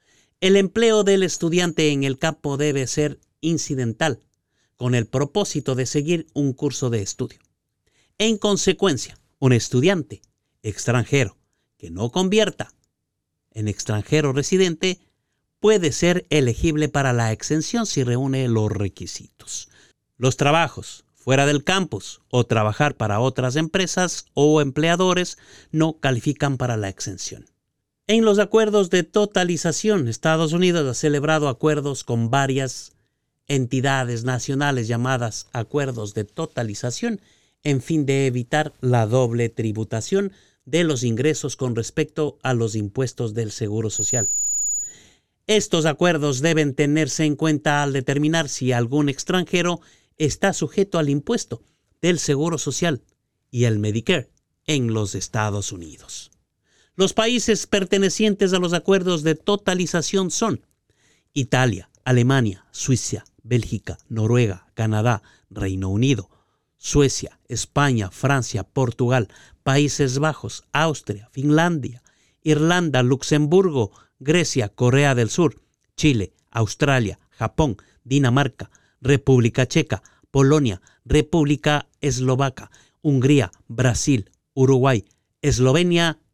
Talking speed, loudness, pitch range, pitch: 115 wpm, -21 LUFS, 115-160 Hz, 135 Hz